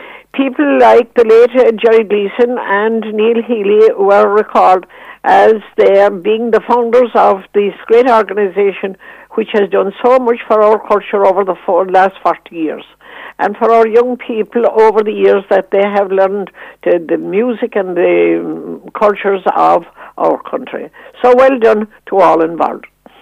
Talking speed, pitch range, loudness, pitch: 155 wpm, 200-235 Hz, -11 LUFS, 215 Hz